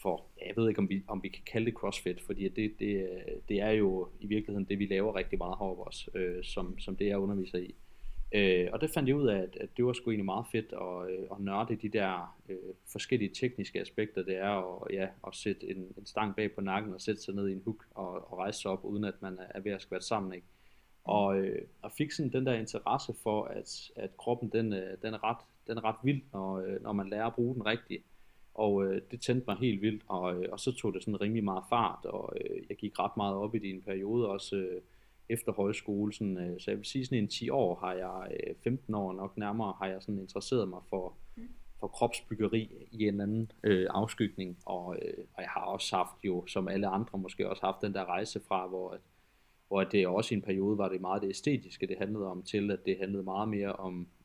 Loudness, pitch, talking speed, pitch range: -35 LUFS, 100 Hz, 250 wpm, 95-110 Hz